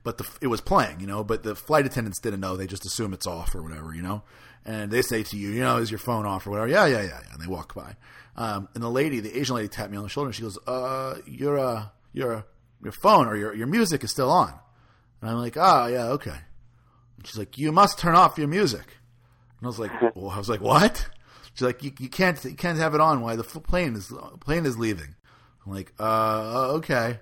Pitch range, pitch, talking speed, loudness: 105-130 Hz, 120 Hz, 255 wpm, -25 LUFS